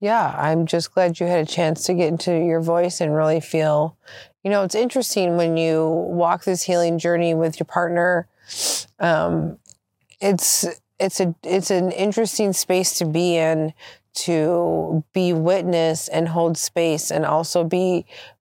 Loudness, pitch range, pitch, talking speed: -20 LUFS, 165-185 Hz, 170 Hz, 160 wpm